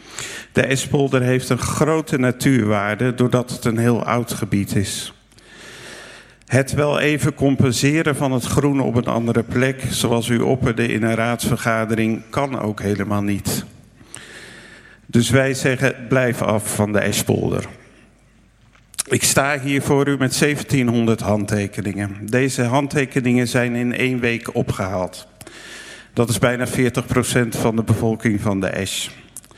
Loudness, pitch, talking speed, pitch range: -19 LUFS, 120 Hz, 135 wpm, 110-130 Hz